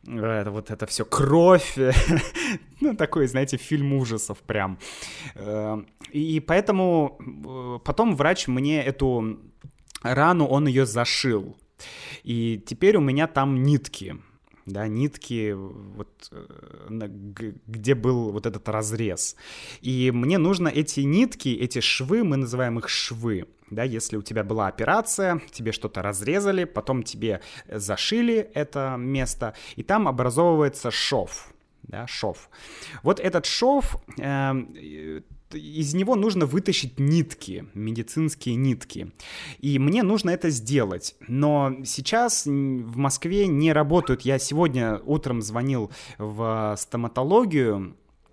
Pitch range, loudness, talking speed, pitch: 110-150 Hz, -24 LUFS, 115 wpm, 130 Hz